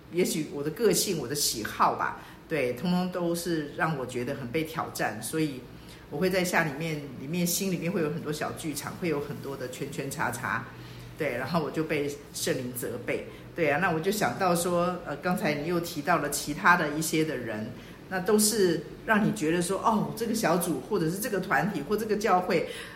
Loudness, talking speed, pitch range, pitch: -28 LUFS, 290 characters per minute, 145-180 Hz, 160 Hz